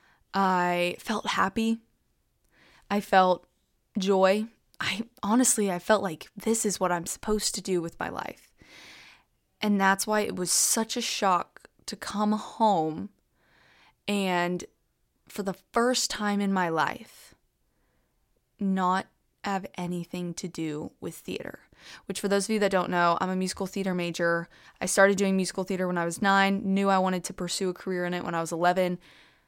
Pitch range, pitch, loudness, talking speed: 180-205 Hz, 190 Hz, -27 LUFS, 165 wpm